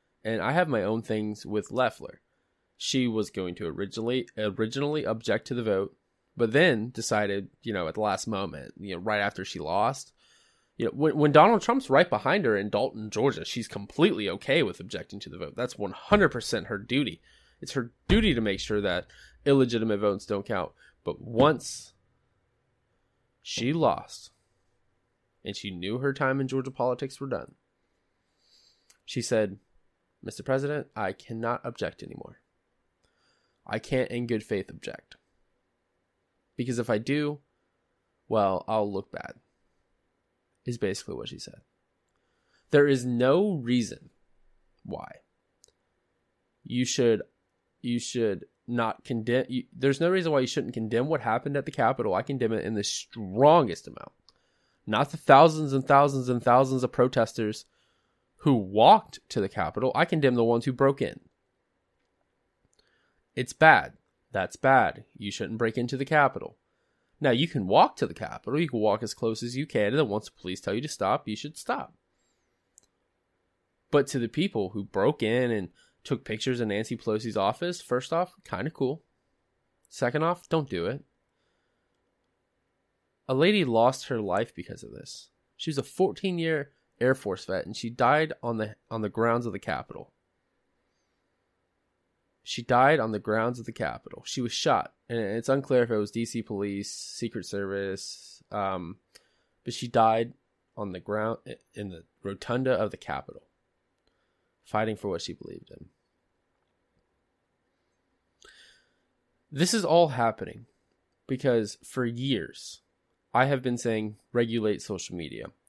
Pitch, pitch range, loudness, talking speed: 120 Hz, 105-135 Hz, -27 LUFS, 160 wpm